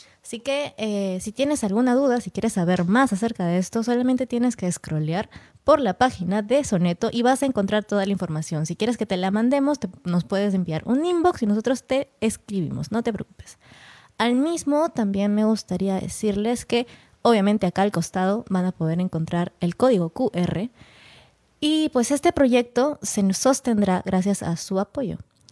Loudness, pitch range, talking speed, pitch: -23 LUFS, 185-250 Hz, 180 wpm, 215 Hz